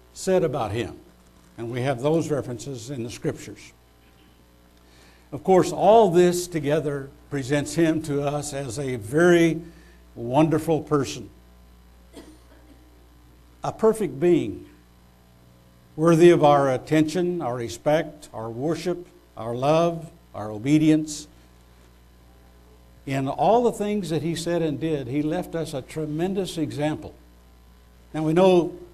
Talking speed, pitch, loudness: 120 wpm, 140 Hz, -23 LUFS